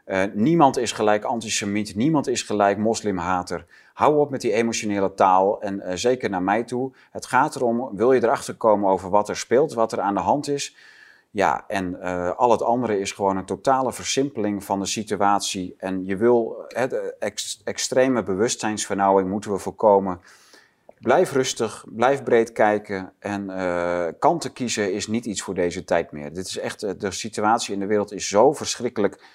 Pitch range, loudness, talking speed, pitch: 95-120 Hz, -22 LUFS, 185 wpm, 105 Hz